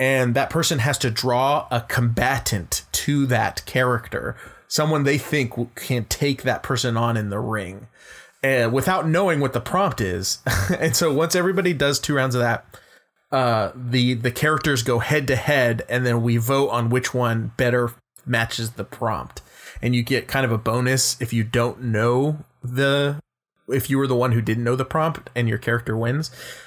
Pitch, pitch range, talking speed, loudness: 125 Hz, 115-140 Hz, 185 wpm, -21 LUFS